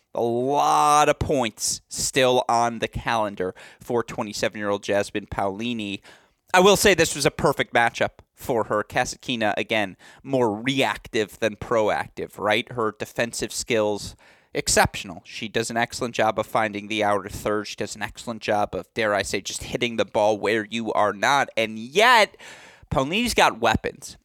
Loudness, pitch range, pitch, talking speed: -23 LUFS, 105-125 Hz, 115 Hz, 165 wpm